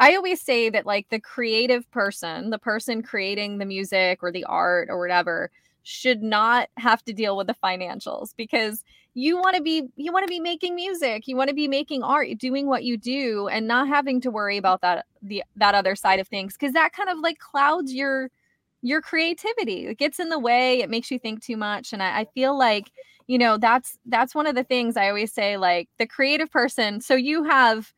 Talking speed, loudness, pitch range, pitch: 220 wpm, -23 LUFS, 210-285 Hz, 245 Hz